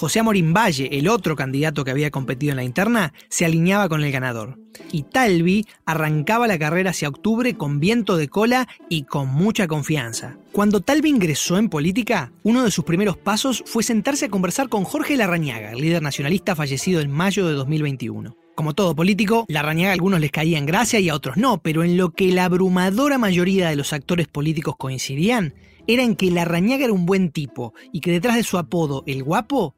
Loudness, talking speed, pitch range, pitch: -20 LUFS, 200 wpm, 150-210 Hz, 175 Hz